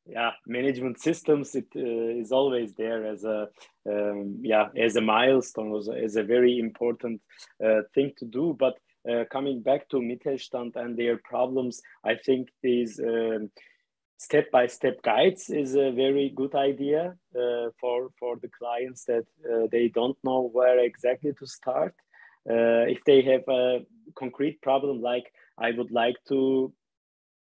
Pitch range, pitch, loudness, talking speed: 115-135 Hz, 125 Hz, -26 LUFS, 160 wpm